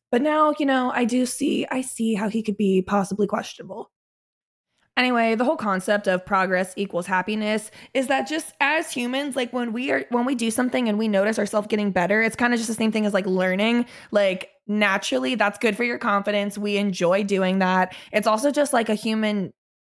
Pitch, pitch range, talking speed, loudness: 220 Hz, 200-250 Hz, 210 wpm, -22 LUFS